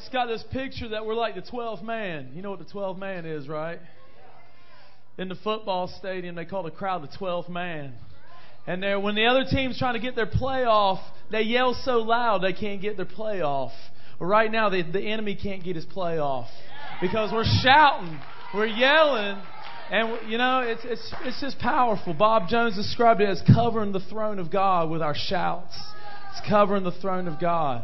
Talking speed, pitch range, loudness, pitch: 195 wpm, 180-225 Hz, -25 LUFS, 200 Hz